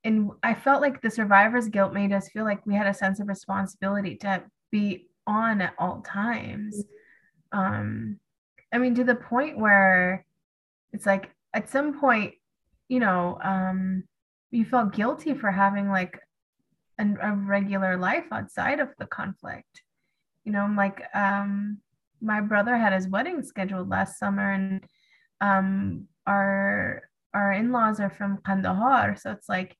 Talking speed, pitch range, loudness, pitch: 155 wpm, 190-220 Hz, -25 LUFS, 200 Hz